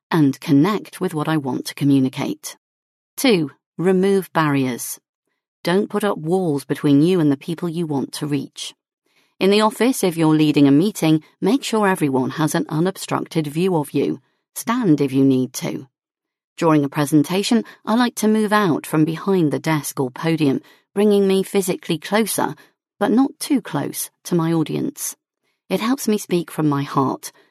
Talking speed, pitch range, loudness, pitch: 170 wpm, 145-195 Hz, -19 LUFS, 165 Hz